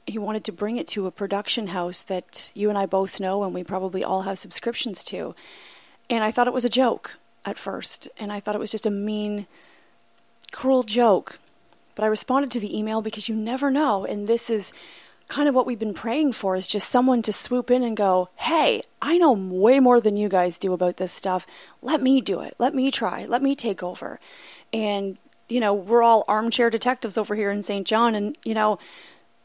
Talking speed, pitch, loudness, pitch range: 220 wpm, 215 Hz, -23 LUFS, 200-245 Hz